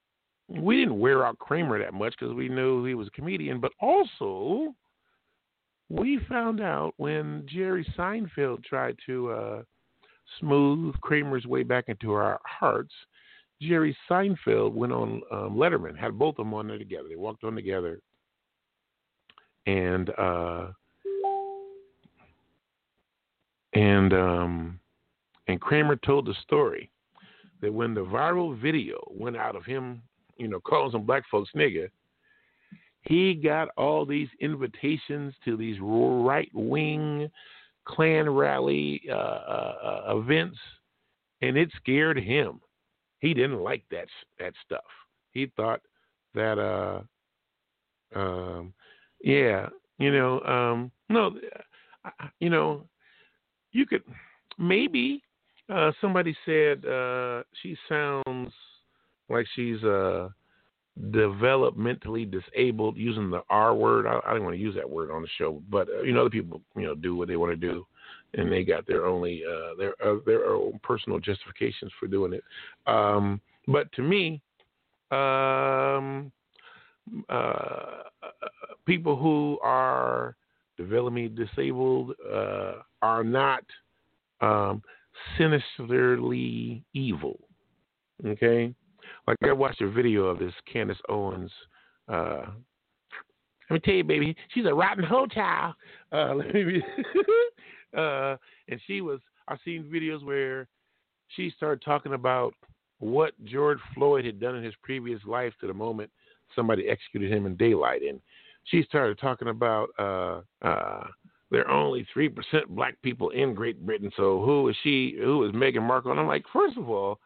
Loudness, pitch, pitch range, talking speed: -27 LUFS, 135 Hz, 110-165 Hz, 140 wpm